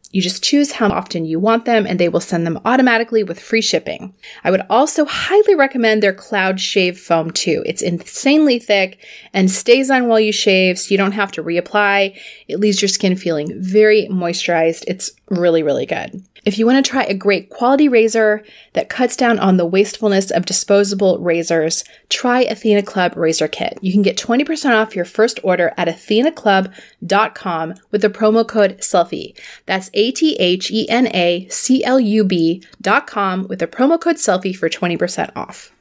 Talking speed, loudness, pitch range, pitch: 180 wpm, -15 LUFS, 180-230 Hz, 205 Hz